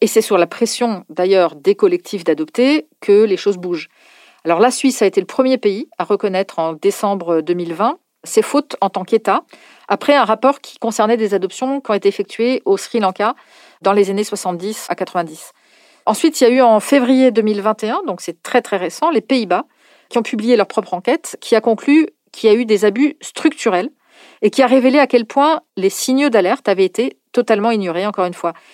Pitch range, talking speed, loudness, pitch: 195-275 Hz, 205 wpm, -16 LUFS, 225 Hz